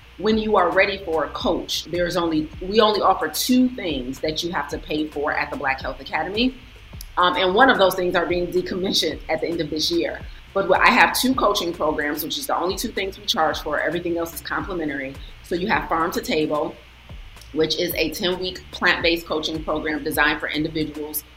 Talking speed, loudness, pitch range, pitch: 215 wpm, -21 LUFS, 155-185 Hz, 165 Hz